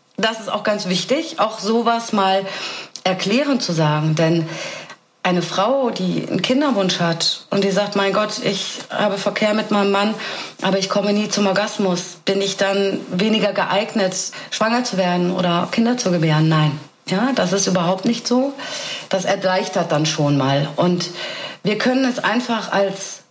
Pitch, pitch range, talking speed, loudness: 195 Hz, 180-215 Hz, 165 wpm, -19 LUFS